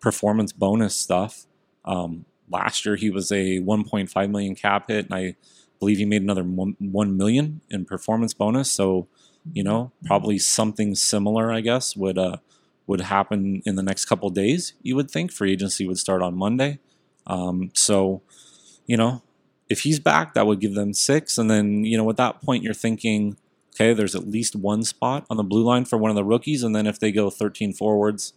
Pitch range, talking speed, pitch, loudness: 100-115 Hz, 200 wpm, 105 Hz, -22 LUFS